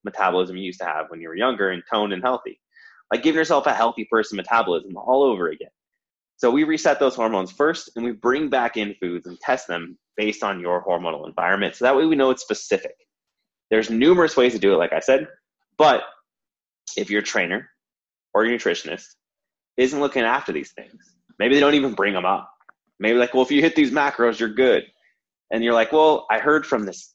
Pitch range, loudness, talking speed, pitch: 100-145 Hz, -21 LUFS, 210 wpm, 120 Hz